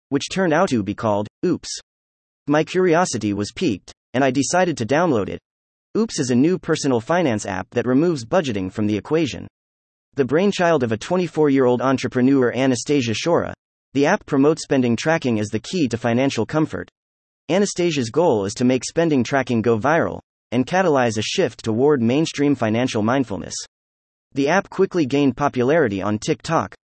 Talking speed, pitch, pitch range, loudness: 170 wpm, 130 Hz, 110-155 Hz, -20 LUFS